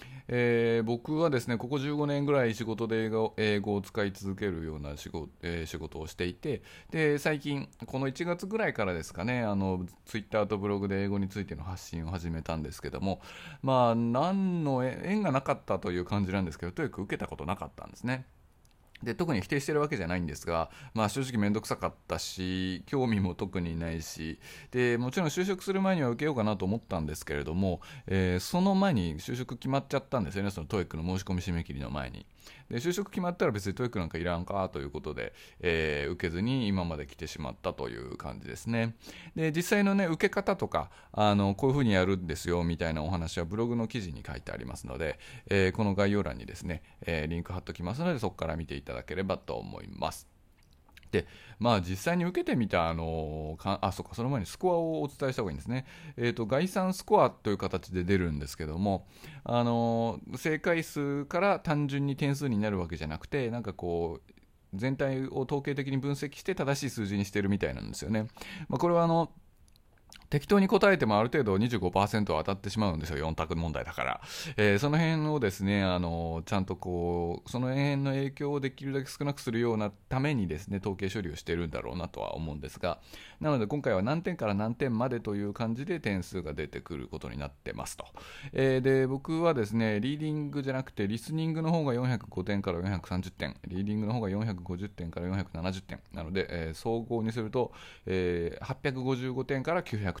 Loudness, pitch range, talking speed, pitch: -32 LUFS, 90-135 Hz, 410 characters per minute, 105 Hz